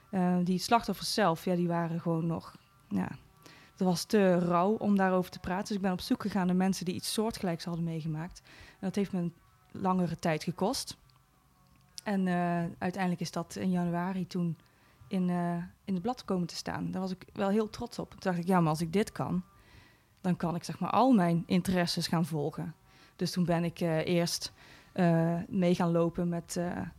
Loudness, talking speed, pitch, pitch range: -31 LUFS, 205 wpm, 180 Hz, 170-190 Hz